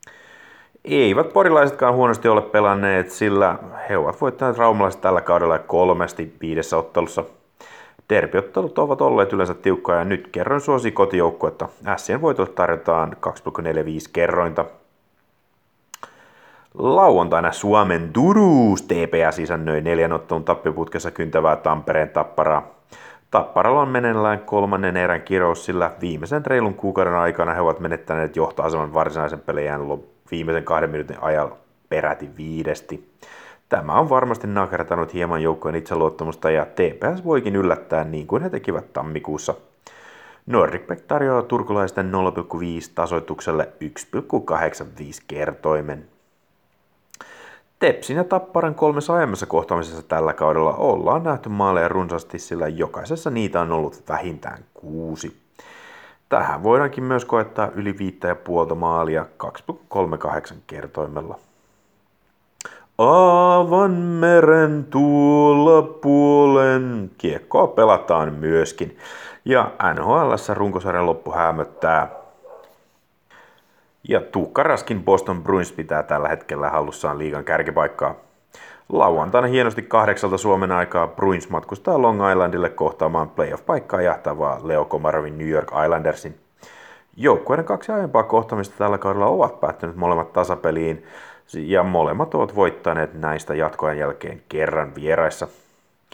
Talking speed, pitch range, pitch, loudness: 110 wpm, 80-125 Hz, 95 Hz, -20 LUFS